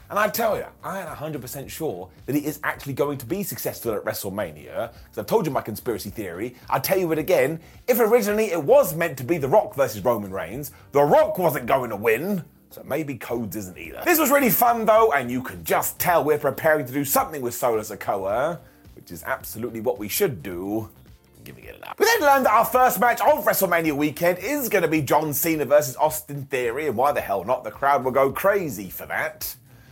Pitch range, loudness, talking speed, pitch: 130-205 Hz, -22 LUFS, 230 wpm, 150 Hz